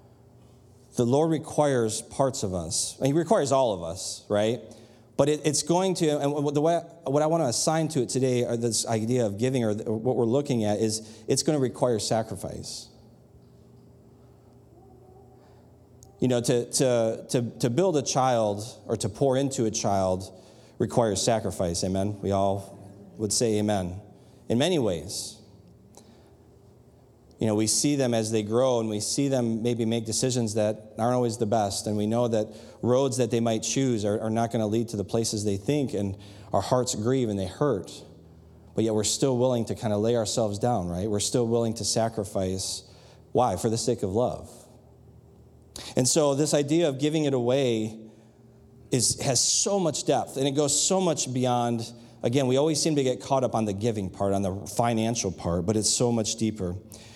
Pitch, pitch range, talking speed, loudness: 115 Hz, 105-130 Hz, 190 wpm, -26 LUFS